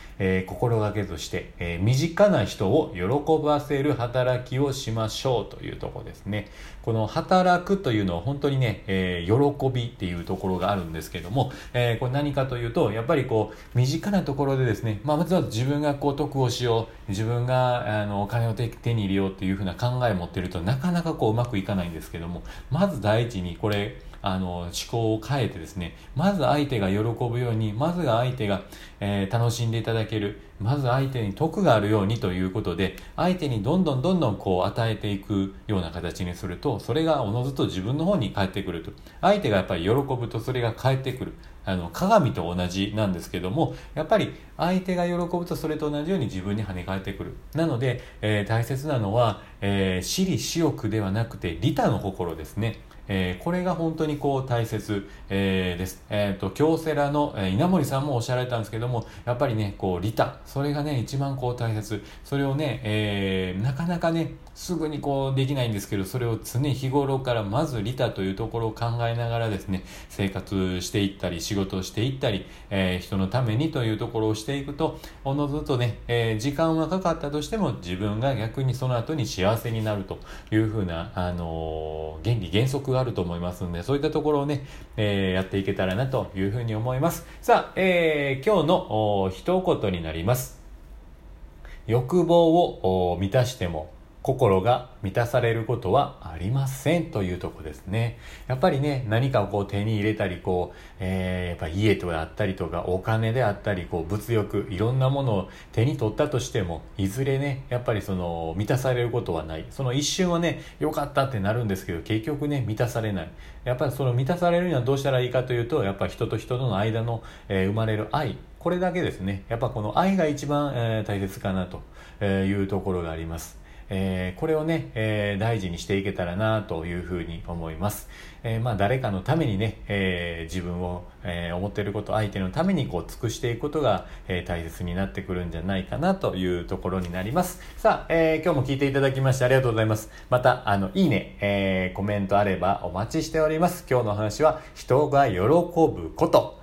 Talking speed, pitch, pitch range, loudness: 400 characters per minute, 110 Hz, 95-140 Hz, -26 LUFS